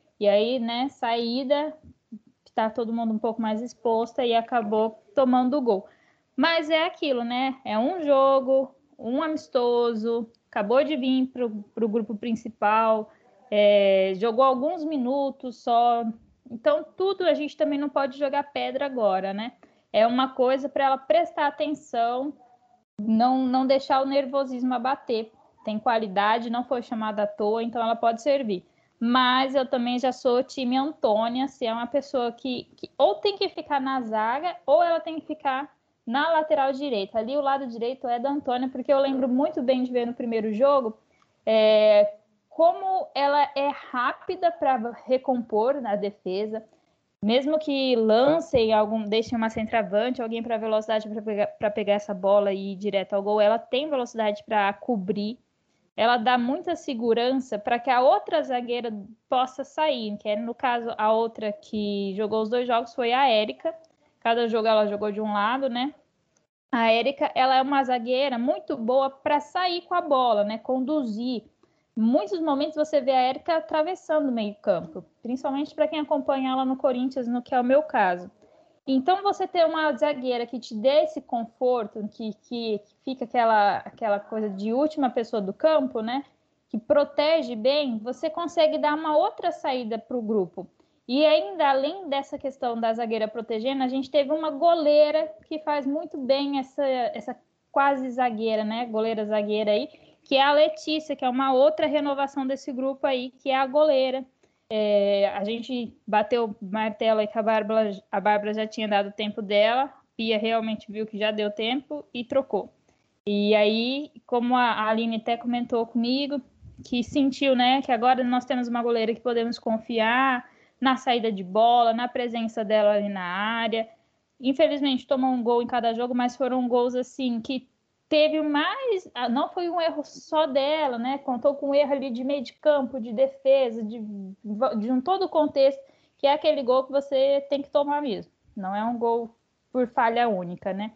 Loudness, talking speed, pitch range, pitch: -25 LUFS, 175 wpm, 225-285 Hz, 255 Hz